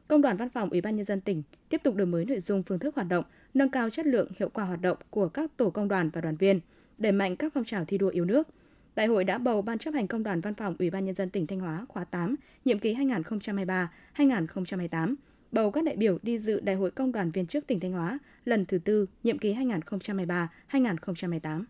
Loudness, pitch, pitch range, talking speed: -29 LUFS, 200 Hz, 185-245 Hz, 245 wpm